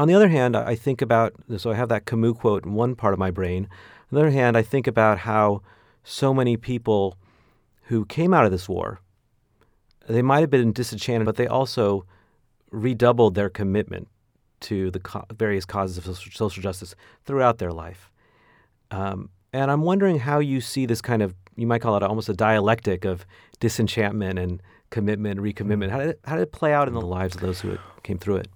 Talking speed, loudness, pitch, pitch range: 200 wpm, -23 LUFS, 110 Hz, 95-120 Hz